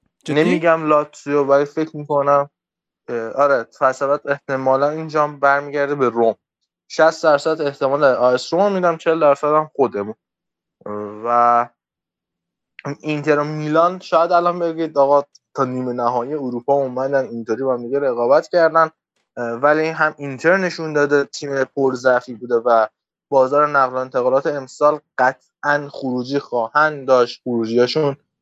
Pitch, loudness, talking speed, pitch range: 140 Hz, -18 LUFS, 120 wpm, 125-150 Hz